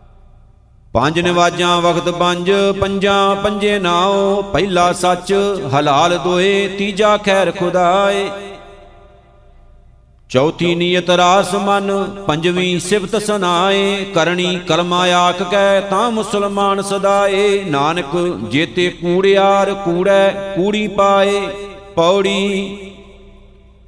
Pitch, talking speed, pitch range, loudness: 190 Hz, 90 wpm, 175-200 Hz, -14 LUFS